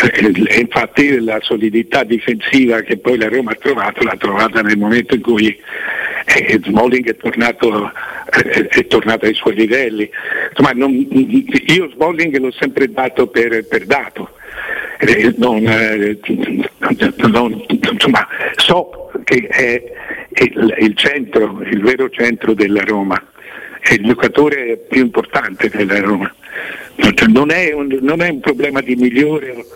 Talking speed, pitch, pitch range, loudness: 130 wpm, 120 Hz, 110-145 Hz, -13 LUFS